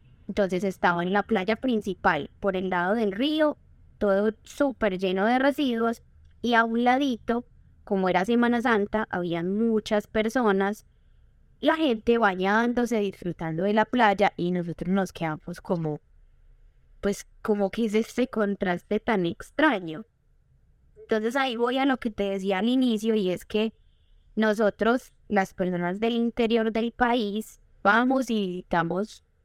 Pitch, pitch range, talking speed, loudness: 215 Hz, 190-235 Hz, 145 wpm, -26 LUFS